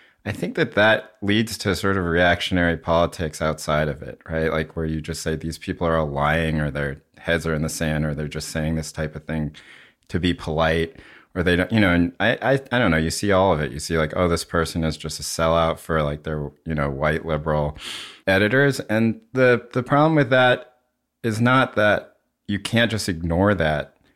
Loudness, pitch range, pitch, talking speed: -22 LUFS, 80-105 Hz, 80 Hz, 225 wpm